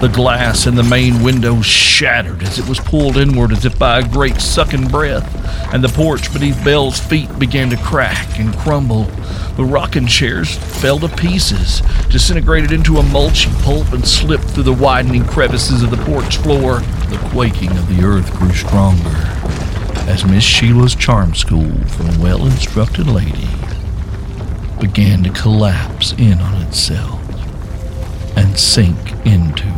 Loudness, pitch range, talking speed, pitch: -13 LUFS, 90-125 Hz, 155 wpm, 100 Hz